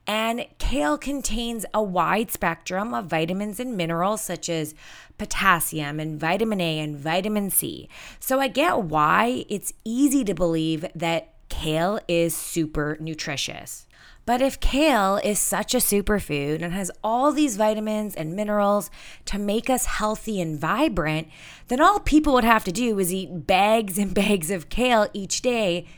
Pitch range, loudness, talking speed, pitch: 165-230 Hz, -23 LUFS, 155 wpm, 205 Hz